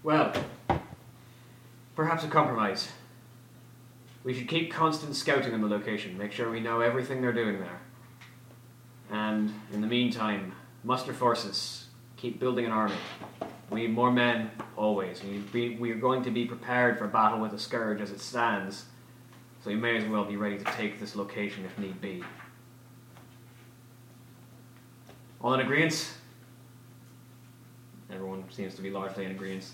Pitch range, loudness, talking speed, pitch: 105-125 Hz, -30 LUFS, 150 wpm, 120 Hz